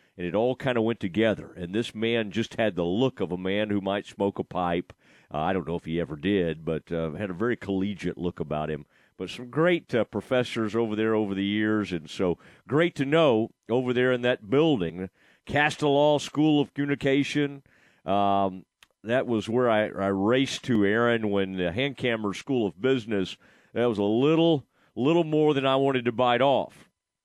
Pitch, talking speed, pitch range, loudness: 110 Hz, 200 wpm, 95-130 Hz, -26 LUFS